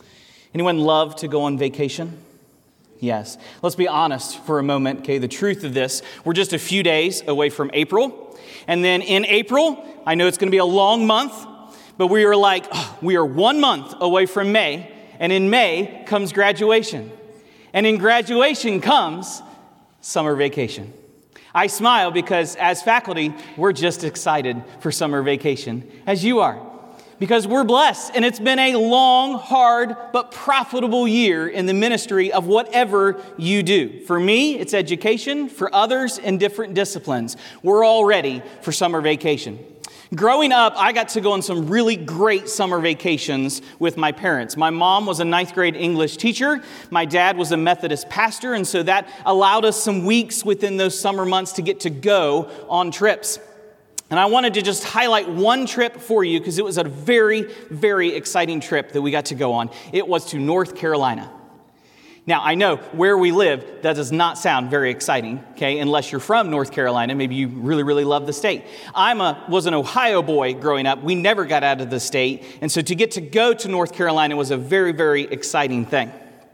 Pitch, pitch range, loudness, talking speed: 185 Hz, 155-220 Hz, -19 LUFS, 185 wpm